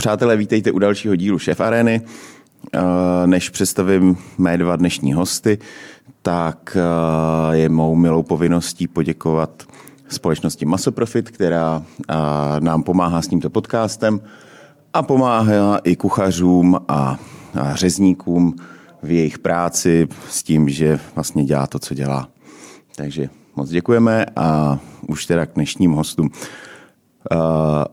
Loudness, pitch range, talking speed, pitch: -18 LUFS, 80-100 Hz, 115 wpm, 85 Hz